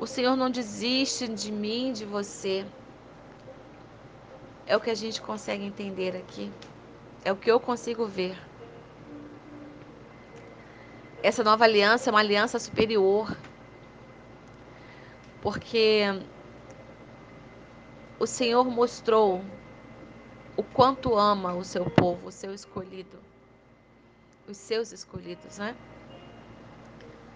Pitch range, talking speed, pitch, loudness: 185-230 Hz, 100 wpm, 205 Hz, -26 LUFS